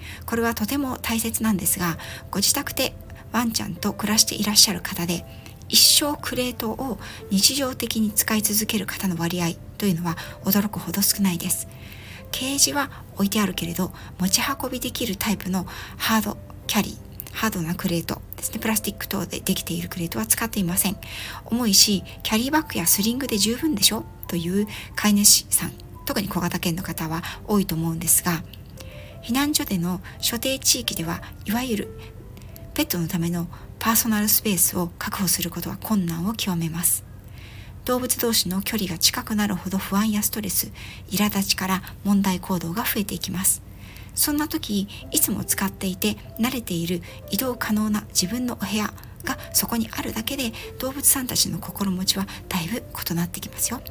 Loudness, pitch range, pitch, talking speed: -22 LUFS, 175-225 Hz, 200 Hz, 360 characters per minute